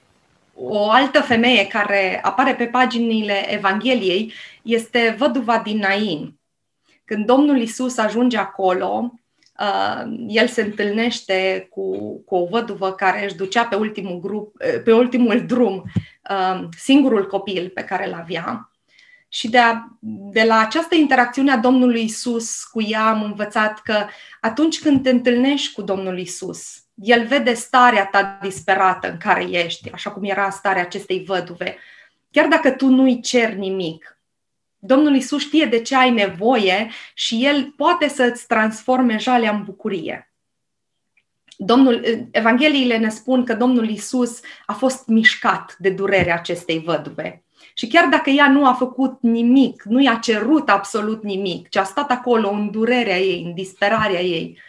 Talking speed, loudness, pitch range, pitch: 145 wpm, -18 LUFS, 195-255 Hz, 225 Hz